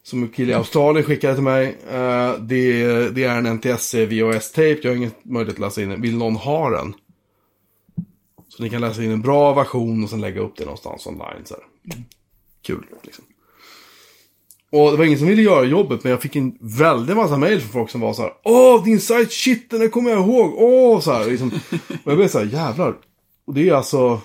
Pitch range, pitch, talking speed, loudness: 115-160 Hz, 125 Hz, 225 wpm, -17 LUFS